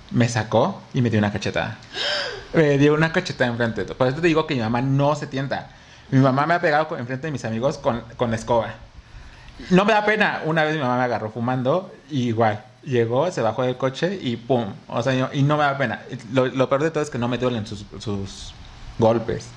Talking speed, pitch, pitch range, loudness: 240 wpm, 125 Hz, 115-145 Hz, -22 LUFS